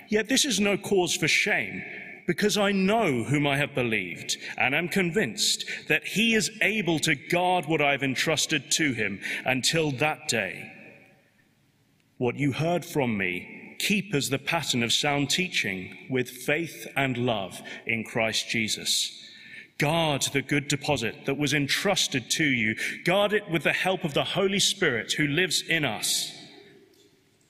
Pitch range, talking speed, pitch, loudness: 125-180 Hz, 160 wpm, 150 Hz, -25 LUFS